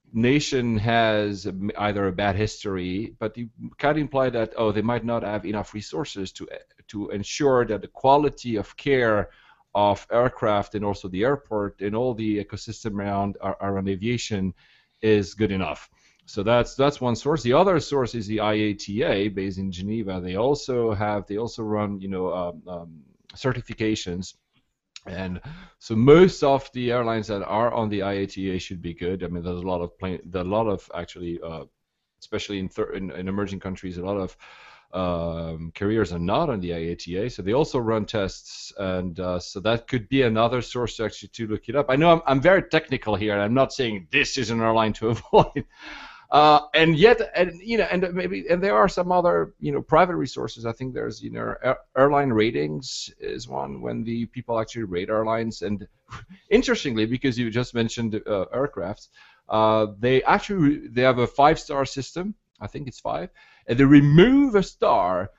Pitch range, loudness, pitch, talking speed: 100-130 Hz, -23 LUFS, 110 Hz, 190 wpm